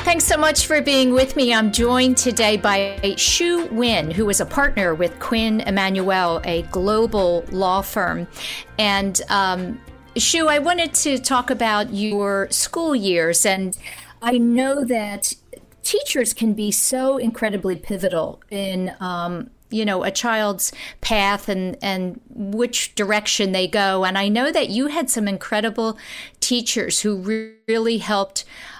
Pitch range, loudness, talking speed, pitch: 195-250 Hz, -19 LUFS, 150 wpm, 215 Hz